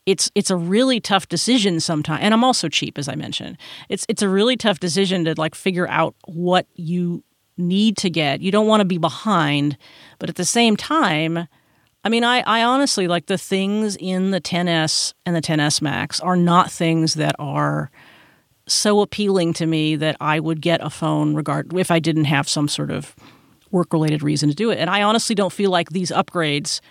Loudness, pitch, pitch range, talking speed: -19 LUFS, 175 Hz, 155-200 Hz, 205 wpm